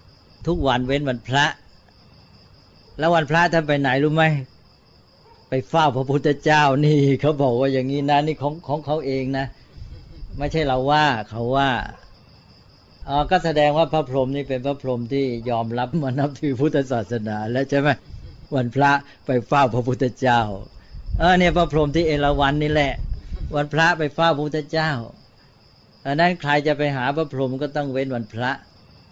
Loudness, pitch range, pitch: -21 LUFS, 130-150 Hz, 140 Hz